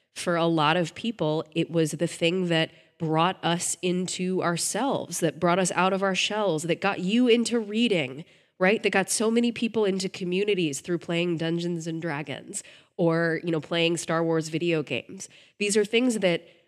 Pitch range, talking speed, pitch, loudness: 165-195 Hz, 185 wpm, 175 Hz, -25 LUFS